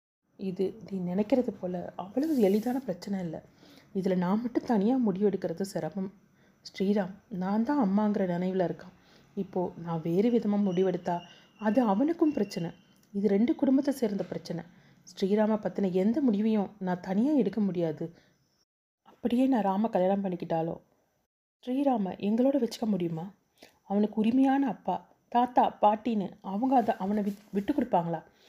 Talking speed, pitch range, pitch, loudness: 130 wpm, 185-230 Hz, 200 Hz, -29 LUFS